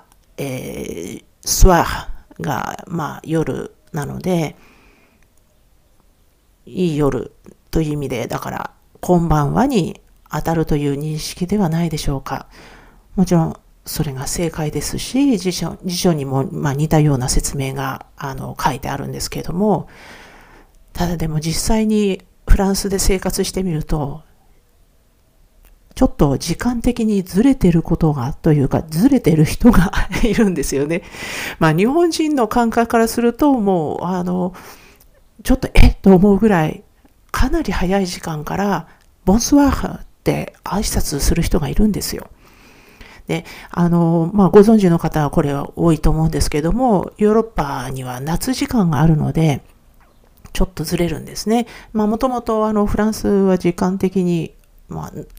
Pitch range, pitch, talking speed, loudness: 150-205 Hz, 175 Hz, 285 characters per minute, -18 LUFS